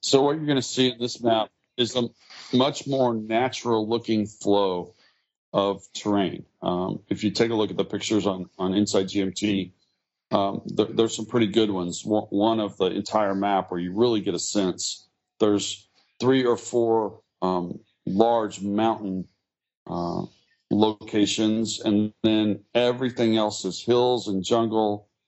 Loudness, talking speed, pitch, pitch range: -24 LUFS, 155 wpm, 105 Hz, 100-115 Hz